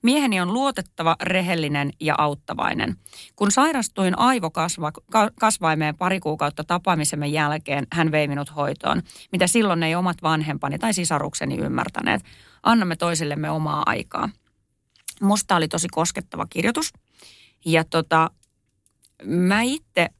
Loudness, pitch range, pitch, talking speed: -22 LUFS, 150-195 Hz, 165 Hz, 115 wpm